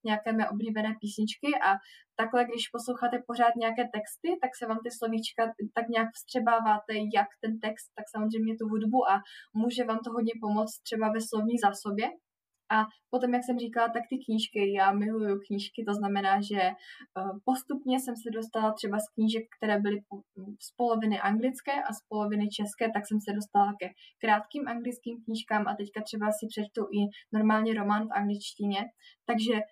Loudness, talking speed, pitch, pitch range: -30 LUFS, 170 wpm, 220 Hz, 210-235 Hz